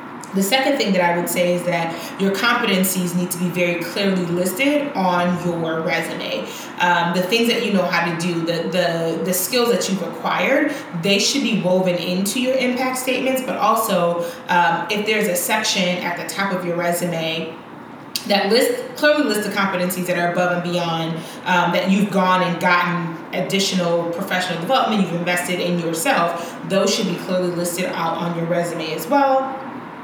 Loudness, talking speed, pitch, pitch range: -19 LUFS, 185 wpm, 180 Hz, 175-210 Hz